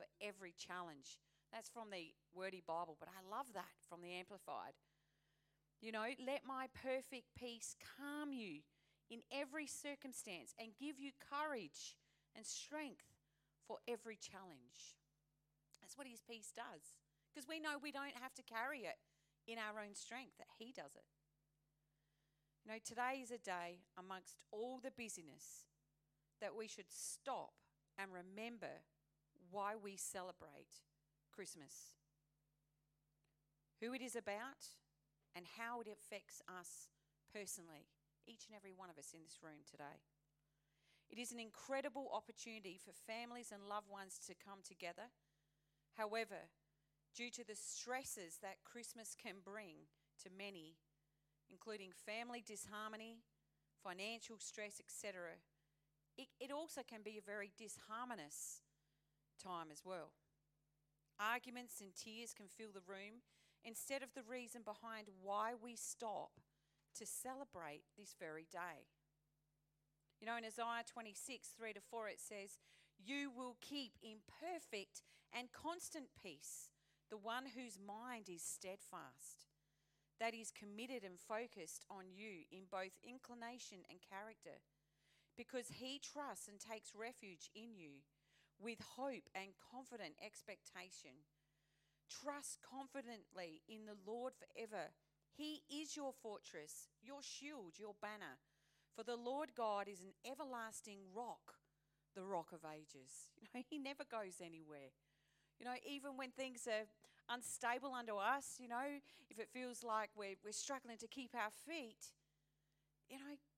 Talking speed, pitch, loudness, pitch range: 140 wpm, 205 Hz, -52 LUFS, 155-240 Hz